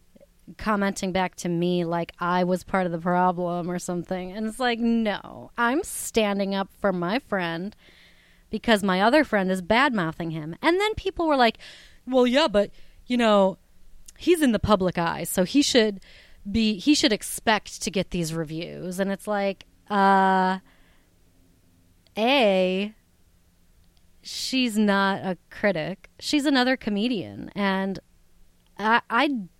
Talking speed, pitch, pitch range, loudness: 145 wpm, 195 Hz, 175-225 Hz, -24 LUFS